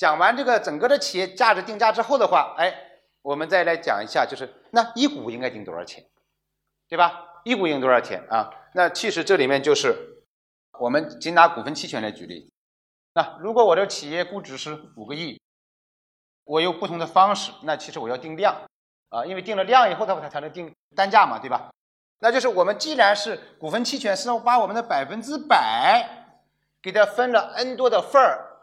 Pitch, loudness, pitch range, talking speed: 200 Hz, -21 LUFS, 165-255 Hz, 290 characters per minute